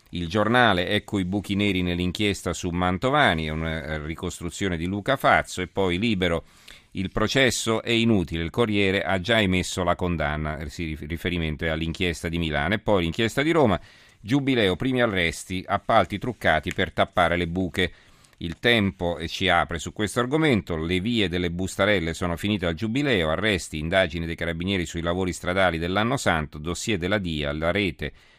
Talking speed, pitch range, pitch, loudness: 165 wpm, 85-105 Hz, 90 Hz, -24 LUFS